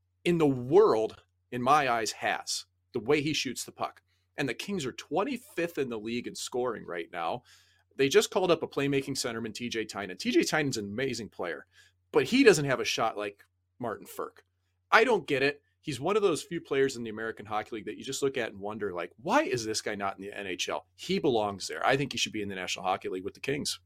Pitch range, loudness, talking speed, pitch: 100-145 Hz, -30 LUFS, 240 wpm, 120 Hz